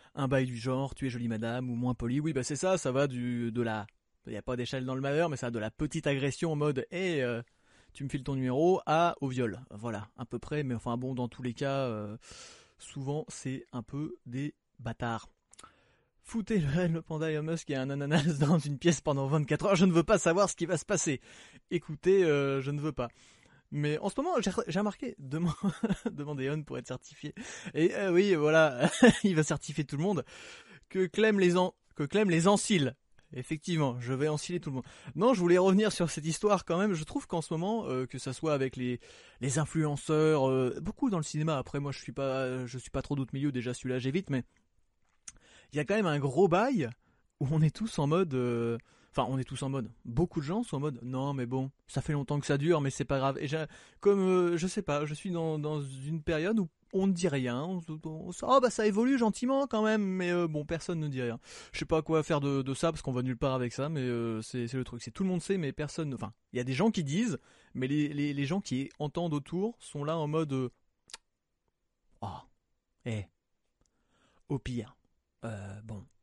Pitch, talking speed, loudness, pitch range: 150 Hz, 235 wpm, -31 LUFS, 130-175 Hz